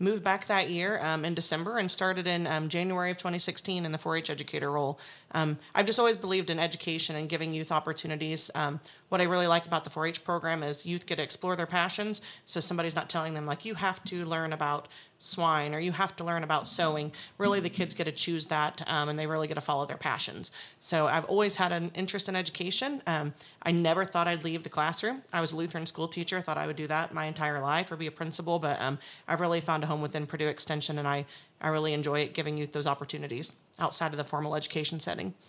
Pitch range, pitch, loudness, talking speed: 155-180 Hz, 165 Hz, -31 LUFS, 240 wpm